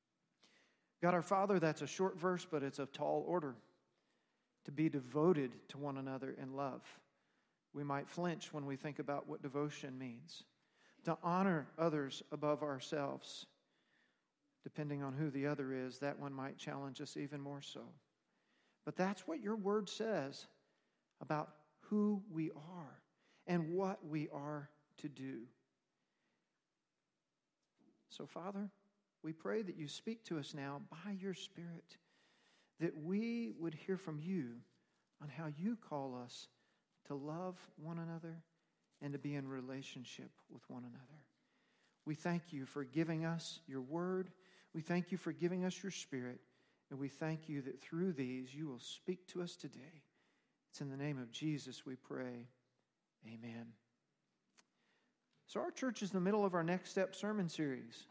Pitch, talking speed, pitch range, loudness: 155 Hz, 155 wpm, 140-180 Hz, -43 LUFS